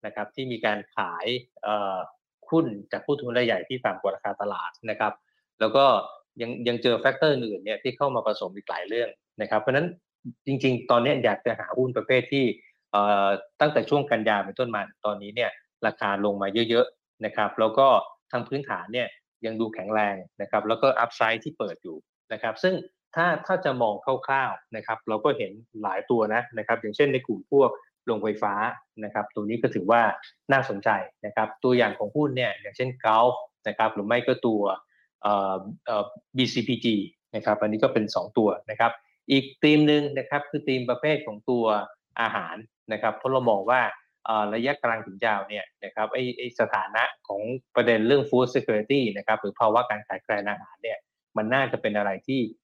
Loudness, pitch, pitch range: -26 LUFS, 120 Hz, 105-130 Hz